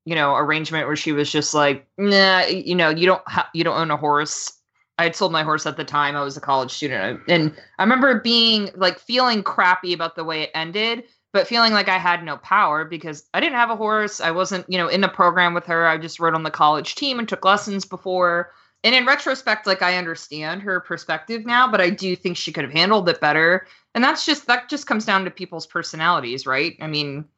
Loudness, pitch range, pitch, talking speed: -19 LUFS, 155-205 Hz, 175 Hz, 240 wpm